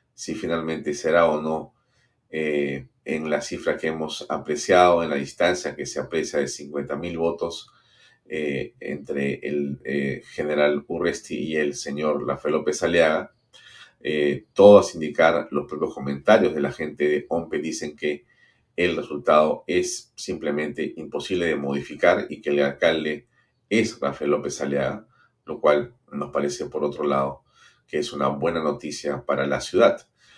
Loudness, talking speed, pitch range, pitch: -23 LUFS, 150 wpm, 70-80 Hz, 75 Hz